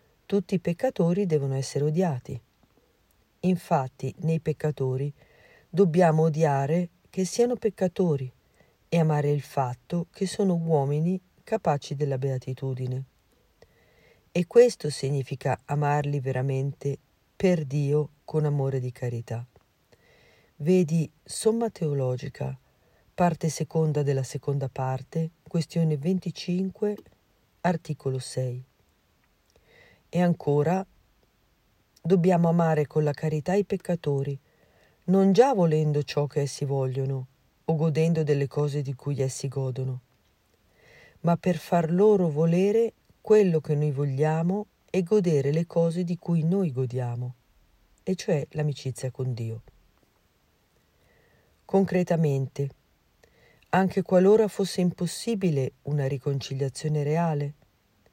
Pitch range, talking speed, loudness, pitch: 135-175 Hz, 105 wpm, -26 LUFS, 150 Hz